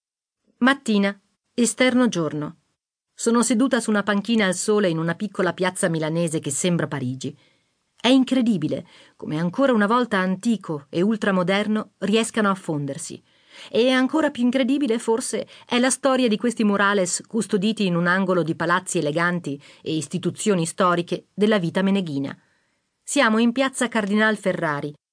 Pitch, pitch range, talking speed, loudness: 200 Hz, 170-230 Hz, 140 wpm, -22 LUFS